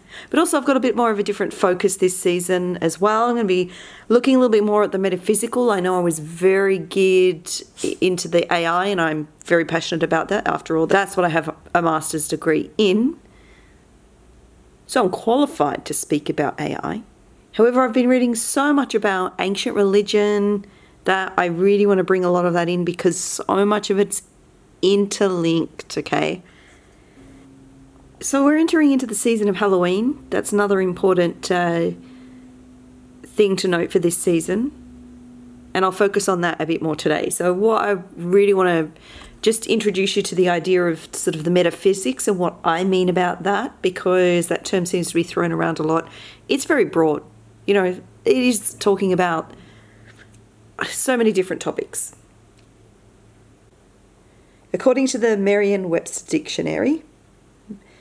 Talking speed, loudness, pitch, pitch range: 170 wpm, -19 LUFS, 185 Hz, 165-210 Hz